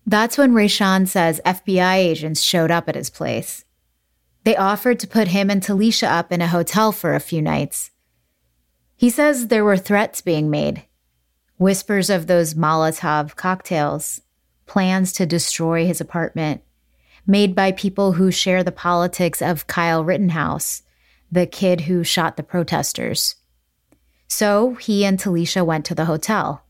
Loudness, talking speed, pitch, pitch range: -18 LUFS, 150 wpm, 175 Hz, 155-195 Hz